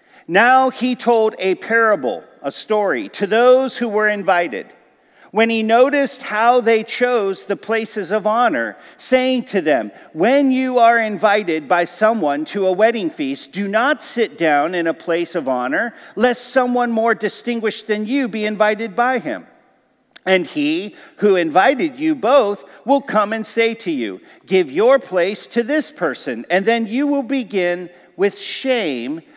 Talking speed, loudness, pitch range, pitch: 160 wpm, -17 LUFS, 205-260 Hz, 225 Hz